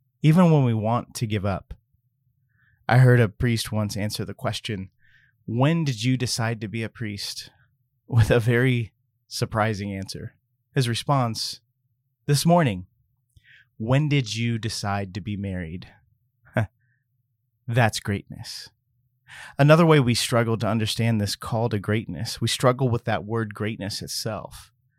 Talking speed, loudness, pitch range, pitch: 140 wpm, -23 LUFS, 110-125 Hz, 120 Hz